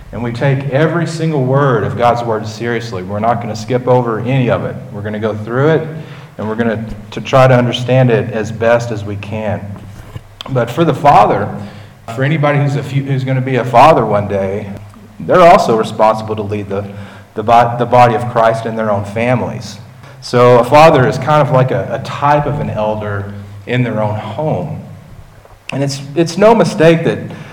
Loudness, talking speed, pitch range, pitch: -13 LUFS, 205 wpm, 110-135 Hz, 120 Hz